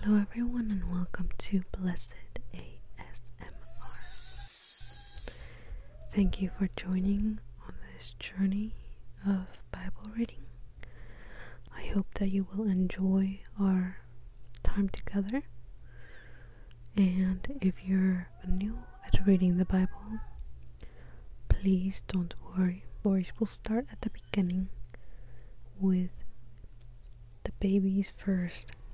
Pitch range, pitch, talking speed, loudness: 120-195 Hz, 185 Hz, 95 wpm, -33 LUFS